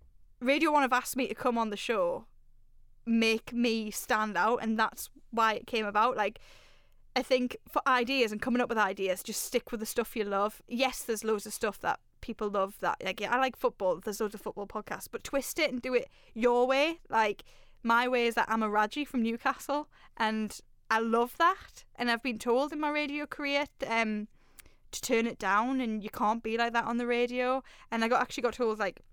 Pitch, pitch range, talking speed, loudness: 235 Hz, 220-255 Hz, 220 wpm, -30 LUFS